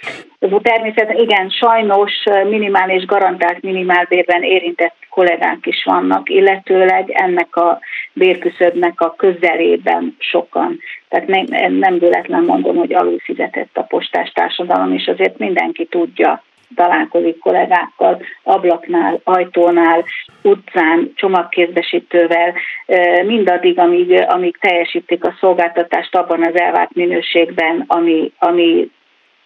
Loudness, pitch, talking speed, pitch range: -14 LUFS, 175 Hz, 100 wpm, 170-195 Hz